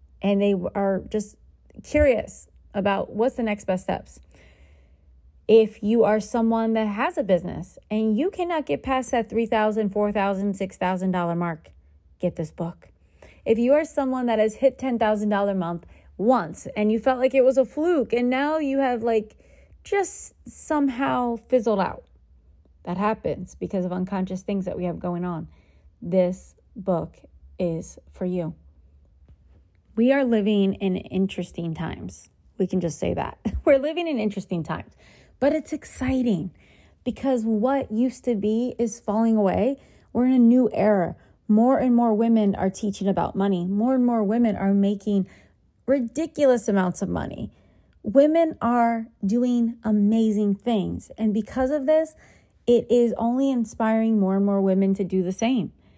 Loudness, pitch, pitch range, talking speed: -23 LUFS, 215 Hz, 185-245 Hz, 160 wpm